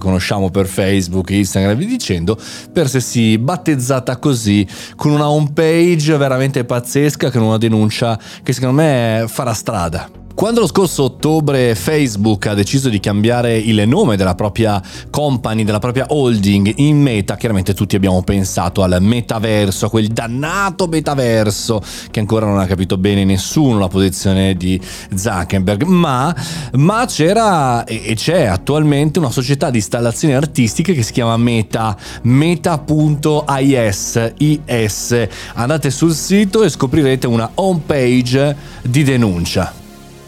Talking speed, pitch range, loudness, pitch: 135 wpm, 100-145 Hz, -14 LUFS, 120 Hz